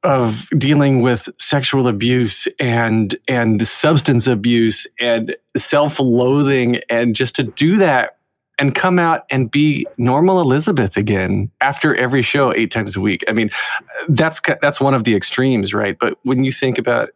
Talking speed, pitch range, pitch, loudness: 160 wpm, 115-145 Hz, 130 Hz, -16 LUFS